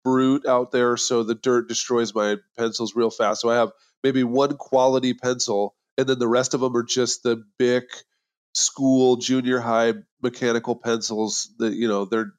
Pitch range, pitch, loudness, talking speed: 115-130 Hz, 120 Hz, -22 LUFS, 180 wpm